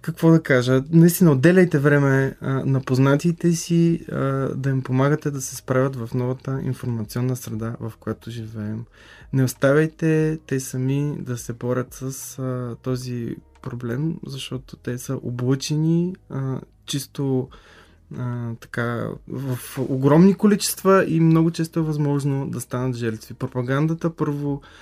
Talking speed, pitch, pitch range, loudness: 135 wpm, 135 Hz, 125-155 Hz, -22 LUFS